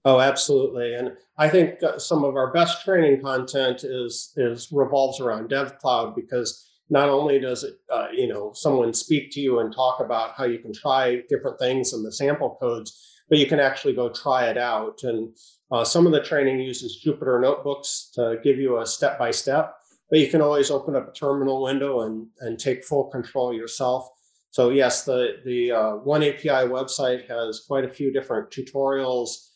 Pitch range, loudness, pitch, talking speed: 125-145 Hz, -23 LUFS, 135 Hz, 195 wpm